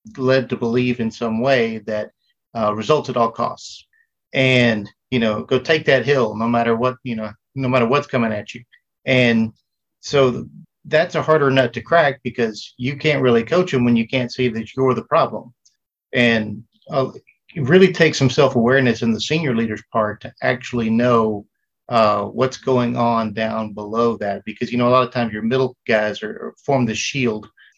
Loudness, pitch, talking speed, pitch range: -18 LUFS, 120 Hz, 195 wpm, 115-130 Hz